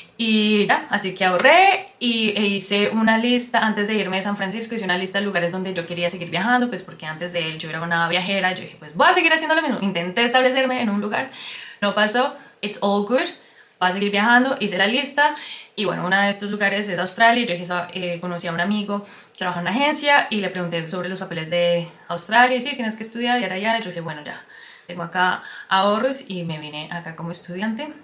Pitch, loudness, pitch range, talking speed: 200 Hz, -20 LUFS, 180-235 Hz, 235 wpm